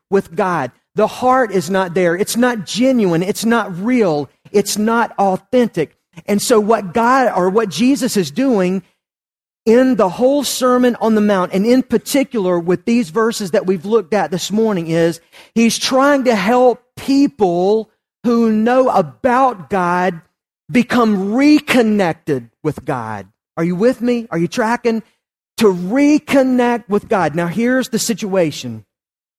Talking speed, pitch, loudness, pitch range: 150 wpm, 215 Hz, -15 LUFS, 185-245 Hz